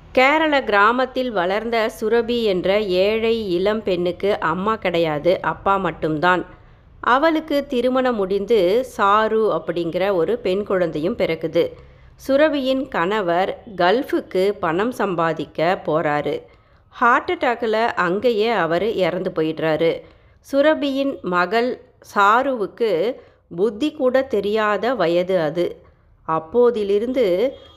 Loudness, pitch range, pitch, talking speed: -19 LUFS, 175-255 Hz, 205 Hz, 90 wpm